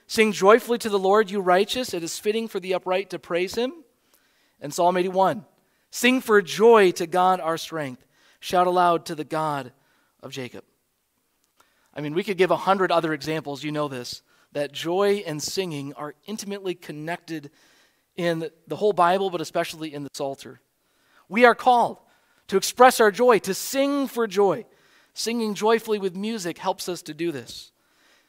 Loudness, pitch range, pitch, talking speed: -23 LUFS, 160-220 Hz, 185 Hz, 170 wpm